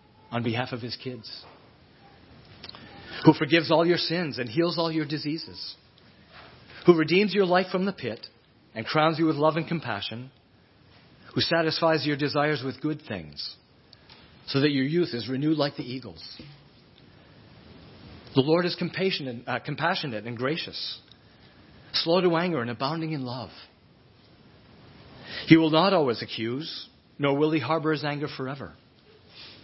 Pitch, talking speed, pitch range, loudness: 150 Hz, 145 wpm, 120-165 Hz, -26 LUFS